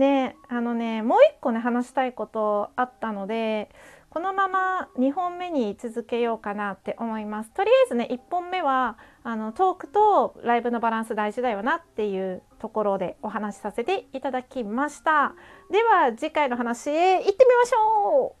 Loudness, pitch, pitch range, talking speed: -24 LUFS, 250 Hz, 225-320 Hz, 335 characters per minute